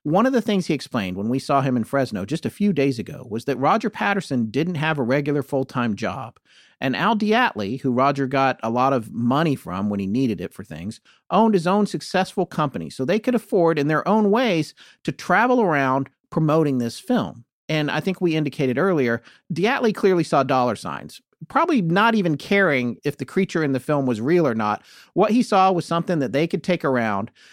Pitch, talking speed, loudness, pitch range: 155 Hz, 215 wpm, -21 LUFS, 130-195 Hz